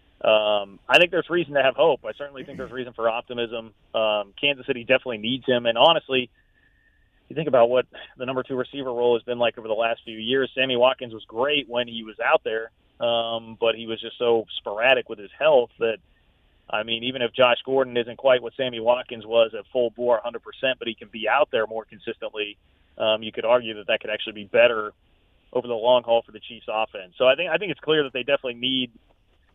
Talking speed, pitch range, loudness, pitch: 235 wpm, 110-130 Hz, -23 LUFS, 120 Hz